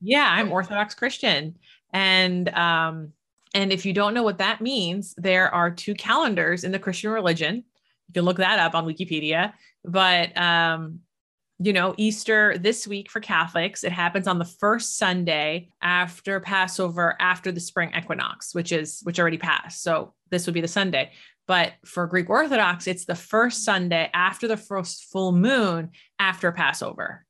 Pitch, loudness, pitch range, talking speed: 185 Hz, -23 LUFS, 170-205 Hz, 165 wpm